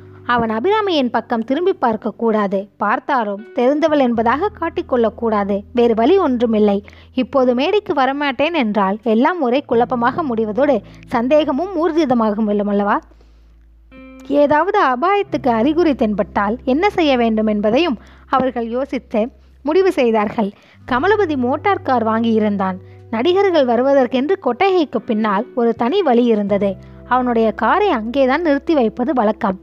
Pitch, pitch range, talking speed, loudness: 245 Hz, 220-290 Hz, 105 wpm, -17 LUFS